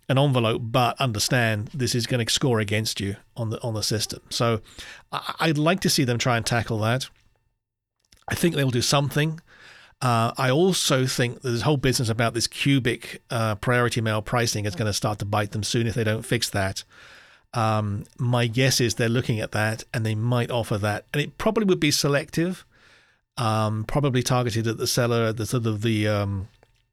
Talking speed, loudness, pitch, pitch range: 200 wpm, -24 LUFS, 120 Hz, 110-130 Hz